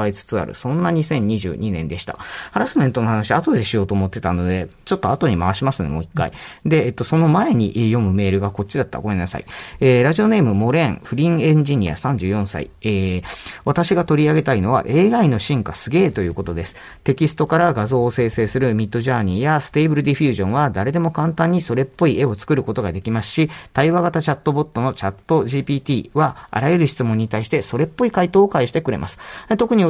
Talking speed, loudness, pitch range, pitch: 450 characters per minute, -19 LUFS, 100-155 Hz, 130 Hz